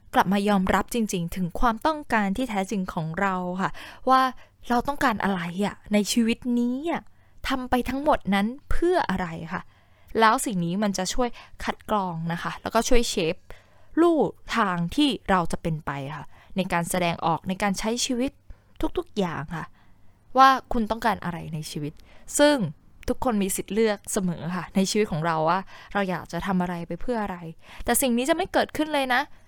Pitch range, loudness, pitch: 180-250 Hz, -25 LUFS, 205 Hz